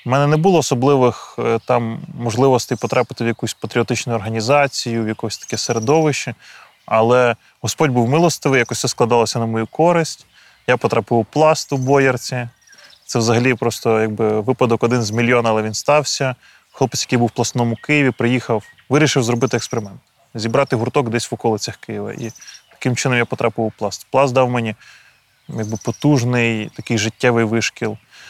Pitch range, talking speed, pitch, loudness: 115-135 Hz, 155 wpm, 120 Hz, -17 LUFS